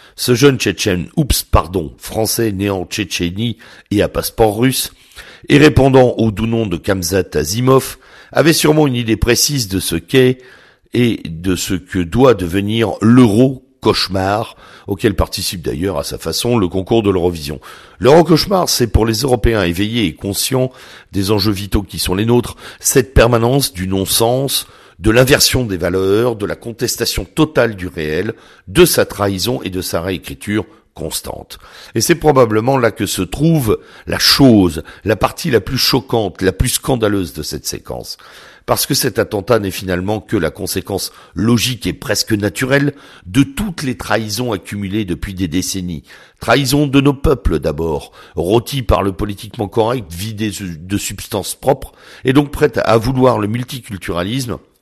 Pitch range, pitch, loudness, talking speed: 95-125 Hz, 110 Hz, -15 LUFS, 160 wpm